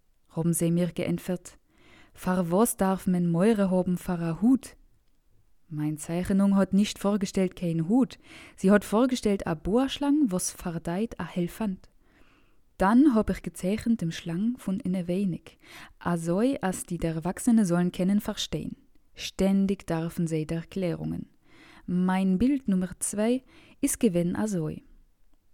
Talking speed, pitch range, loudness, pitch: 135 wpm, 175-215 Hz, -27 LUFS, 185 Hz